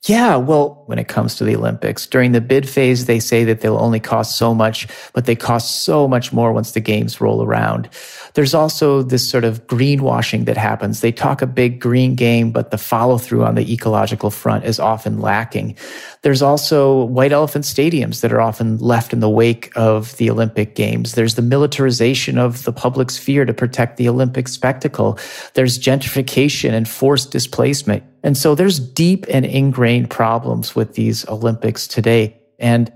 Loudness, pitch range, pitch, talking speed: -16 LUFS, 115-135 Hz, 120 Hz, 185 wpm